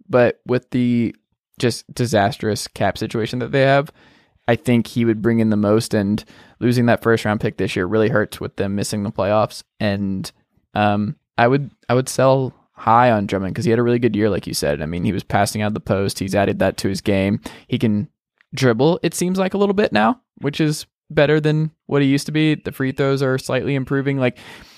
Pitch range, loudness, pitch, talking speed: 105-135 Hz, -19 LUFS, 120 Hz, 225 wpm